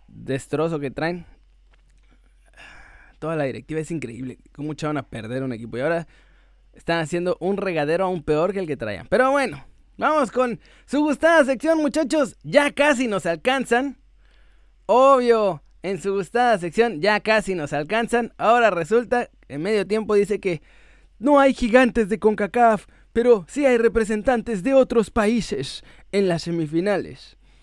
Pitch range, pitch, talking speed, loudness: 165-245 Hz, 210 Hz, 150 wpm, -21 LUFS